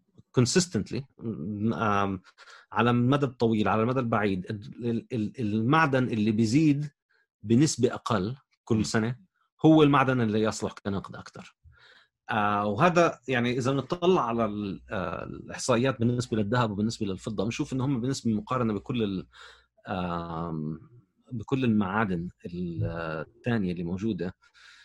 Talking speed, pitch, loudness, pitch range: 100 wpm, 115 Hz, -27 LUFS, 105-130 Hz